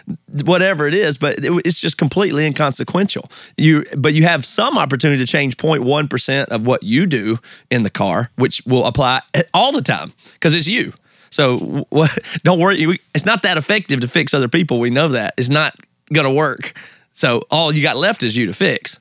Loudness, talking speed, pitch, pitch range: -16 LUFS, 195 wpm, 155 Hz, 135-170 Hz